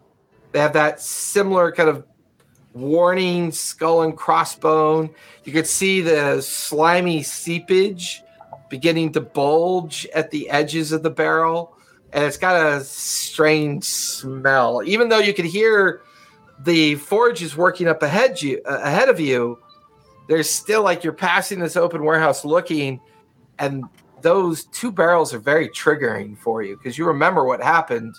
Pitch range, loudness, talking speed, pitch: 145-175 Hz, -19 LUFS, 145 wpm, 160 Hz